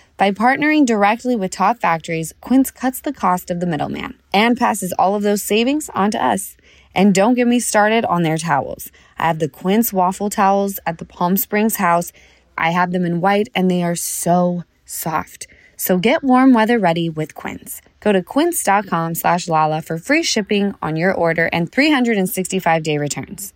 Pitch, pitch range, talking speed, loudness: 190 Hz, 170-225 Hz, 185 wpm, -17 LUFS